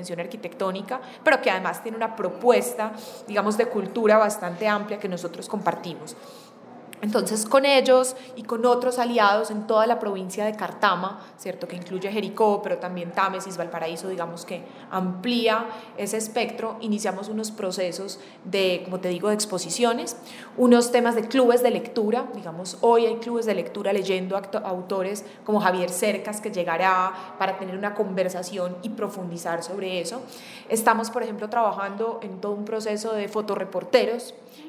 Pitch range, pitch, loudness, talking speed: 185-230 Hz, 210 Hz, -24 LUFS, 150 wpm